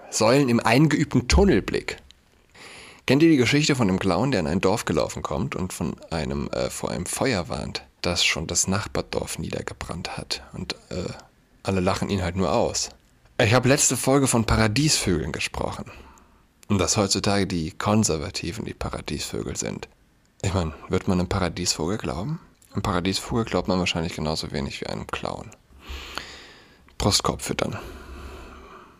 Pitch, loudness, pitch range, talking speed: 95 Hz, -24 LUFS, 85-120 Hz, 150 wpm